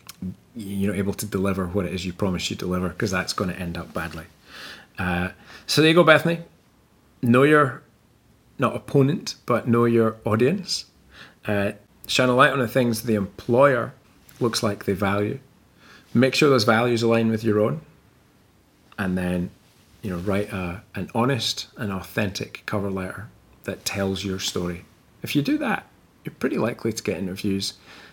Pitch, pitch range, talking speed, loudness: 105 Hz, 95-120 Hz, 170 wpm, -23 LUFS